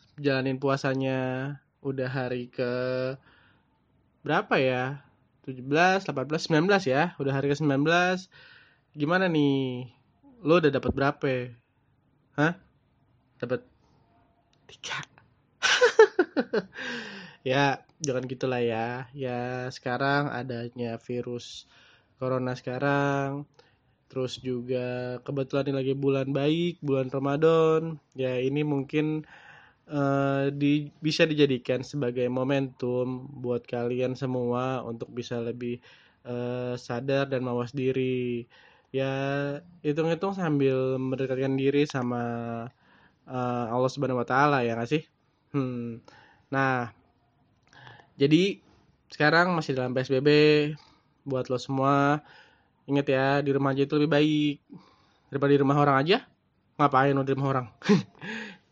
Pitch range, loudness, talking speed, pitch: 125-145 Hz, -27 LUFS, 105 wpm, 135 Hz